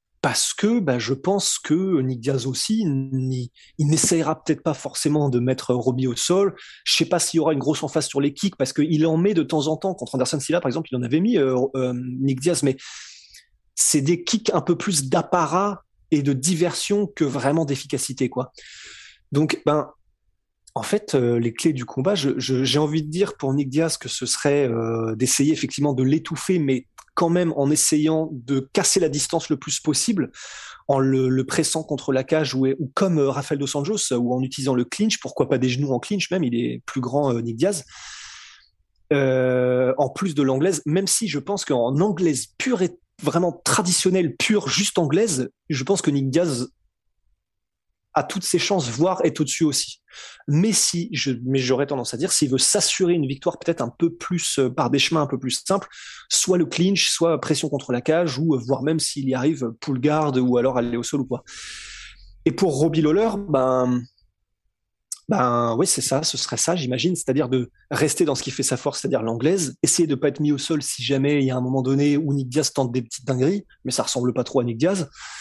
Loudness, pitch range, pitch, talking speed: -21 LUFS, 130-165 Hz, 145 Hz, 220 wpm